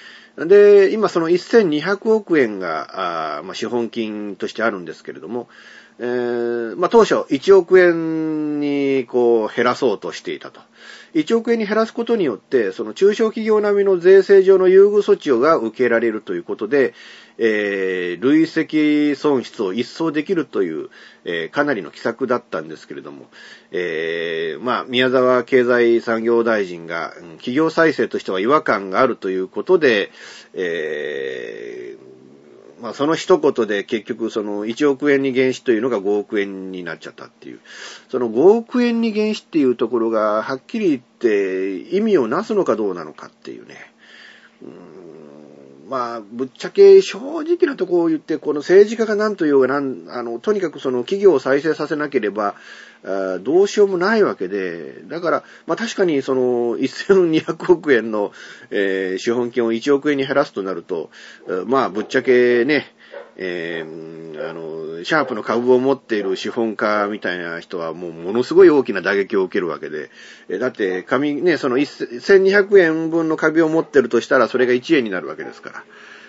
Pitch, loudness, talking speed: 155 Hz, -18 LUFS, 315 characters per minute